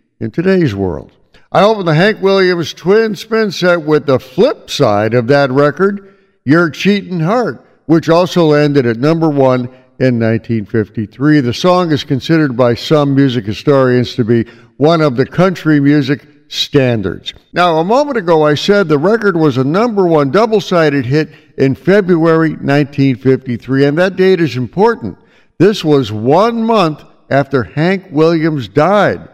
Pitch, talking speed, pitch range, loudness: 150 Hz, 155 wpm, 135-180 Hz, -12 LUFS